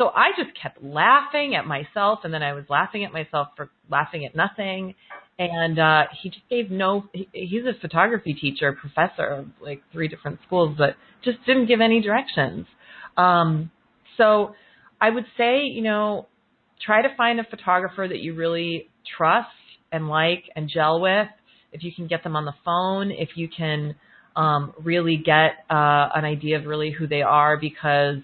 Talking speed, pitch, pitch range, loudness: 175 wpm, 165 Hz, 150-205 Hz, -22 LUFS